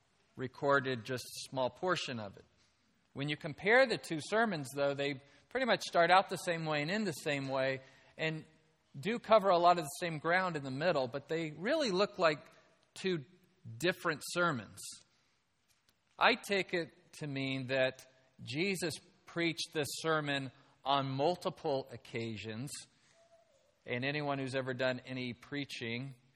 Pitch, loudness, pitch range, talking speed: 150 Hz, -34 LUFS, 135-175 Hz, 155 wpm